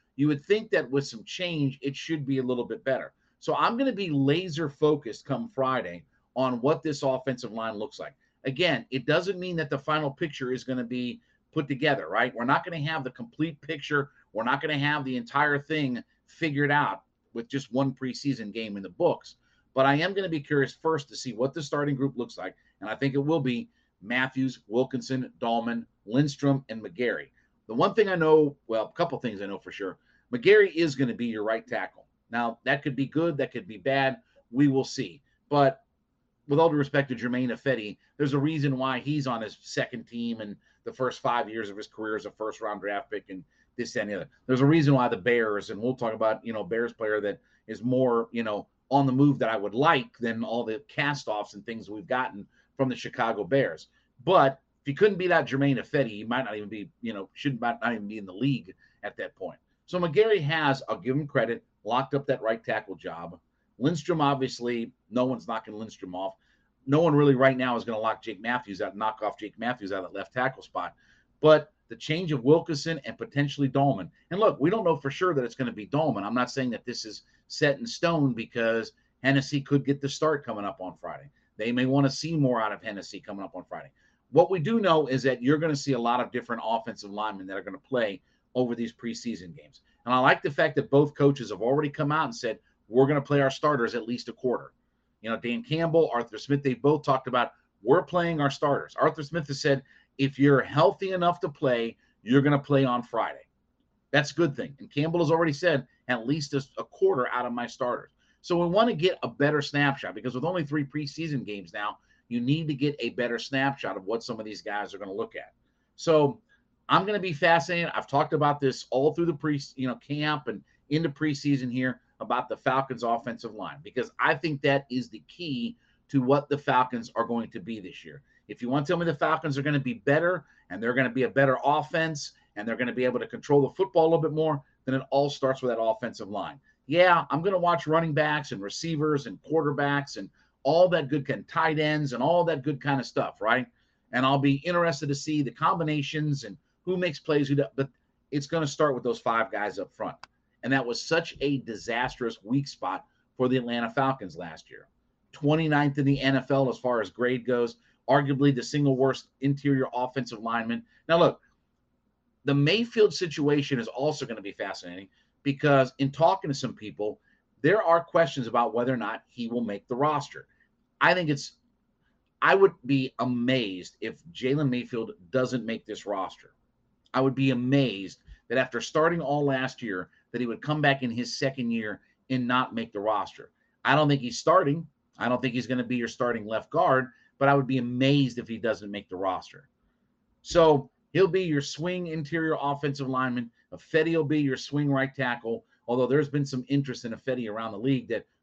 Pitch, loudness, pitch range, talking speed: 135 Hz, -27 LUFS, 120-150 Hz, 225 wpm